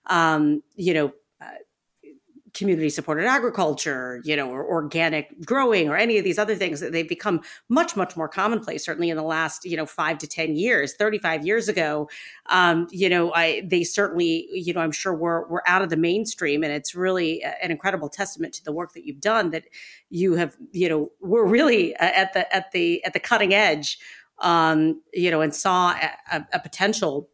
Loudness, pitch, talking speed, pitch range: -22 LUFS, 170 Hz, 200 wpm, 160-200 Hz